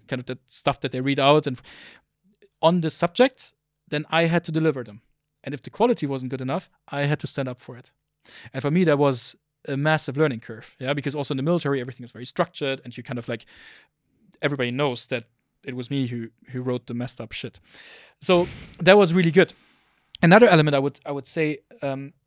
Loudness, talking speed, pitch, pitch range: -23 LUFS, 220 wpm, 140 Hz, 125-155 Hz